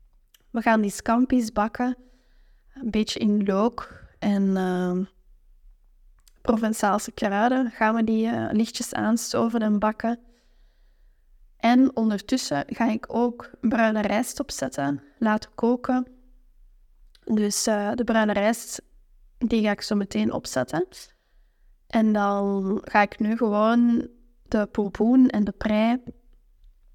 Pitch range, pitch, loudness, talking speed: 205-240 Hz, 220 Hz, -24 LUFS, 120 wpm